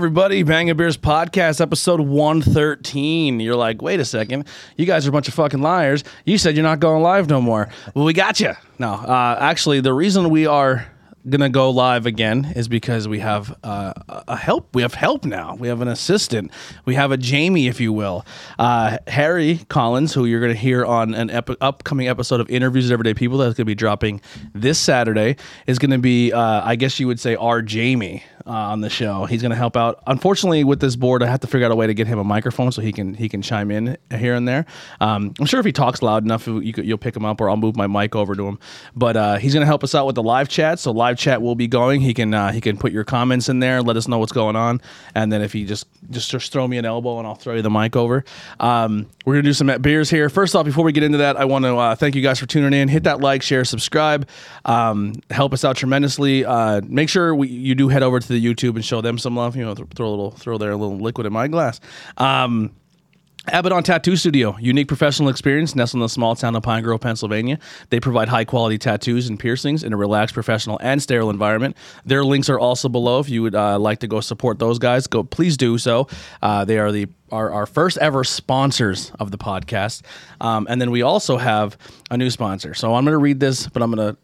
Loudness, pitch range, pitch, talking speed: -18 LUFS, 115-140 Hz, 125 Hz, 250 wpm